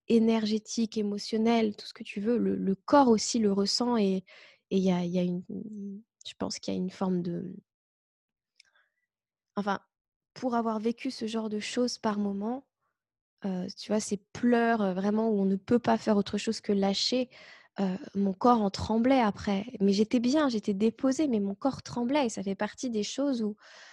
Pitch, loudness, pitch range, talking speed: 215 Hz, -29 LUFS, 200-235 Hz, 190 wpm